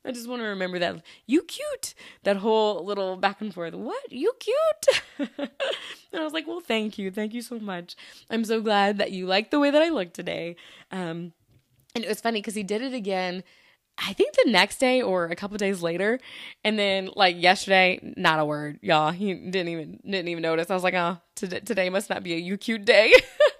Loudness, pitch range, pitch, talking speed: -25 LUFS, 180-240 Hz, 200 Hz, 225 wpm